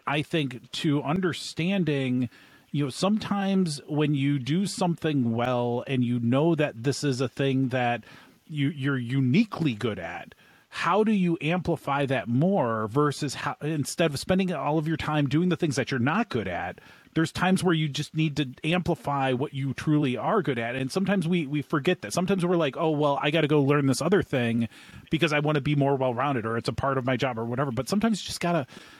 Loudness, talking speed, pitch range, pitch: -26 LUFS, 210 wpm, 130-170 Hz, 145 Hz